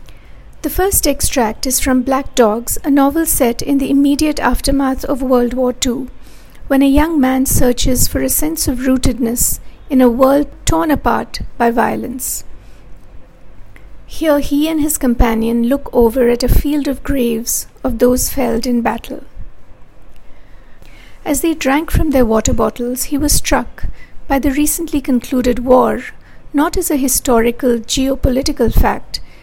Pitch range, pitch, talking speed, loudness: 245-285 Hz, 265 Hz, 150 wpm, -14 LUFS